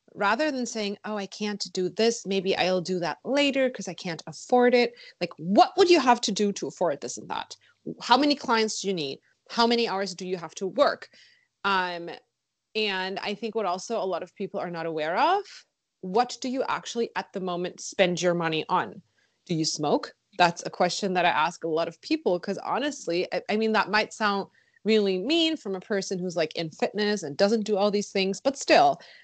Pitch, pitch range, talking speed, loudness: 200 Hz, 180-230 Hz, 220 wpm, -26 LUFS